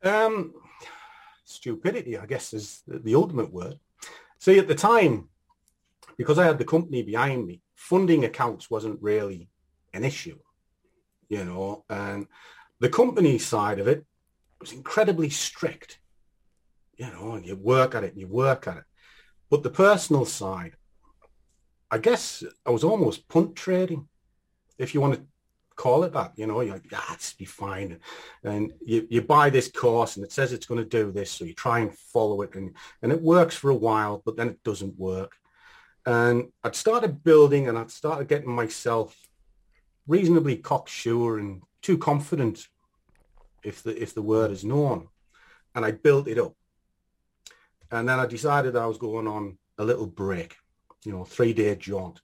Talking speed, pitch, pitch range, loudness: 170 wpm, 115 Hz, 100-150 Hz, -25 LUFS